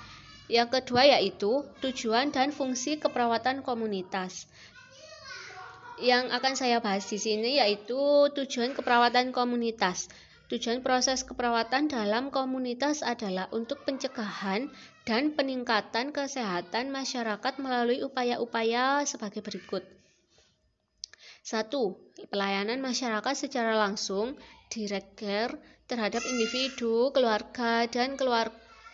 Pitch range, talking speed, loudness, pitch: 220-265 Hz, 95 wpm, -29 LUFS, 240 Hz